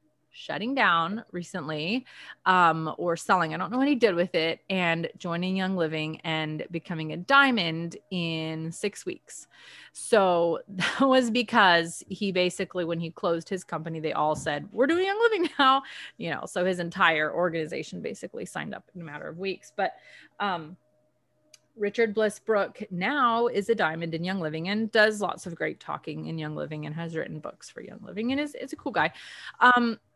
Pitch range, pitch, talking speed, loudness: 165-225 Hz, 180 Hz, 185 wpm, -26 LUFS